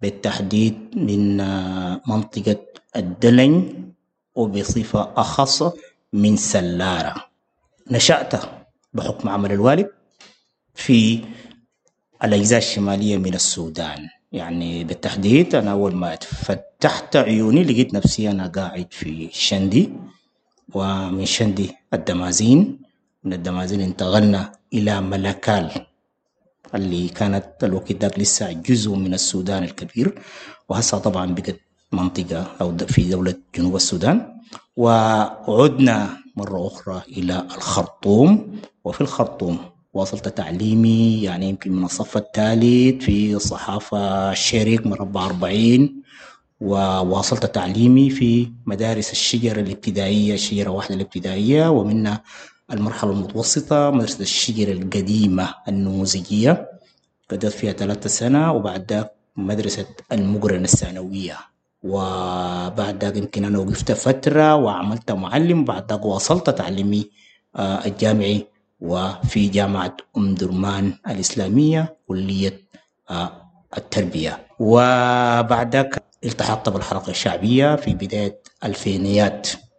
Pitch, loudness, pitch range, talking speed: 100 Hz, -19 LUFS, 95-115 Hz, 95 wpm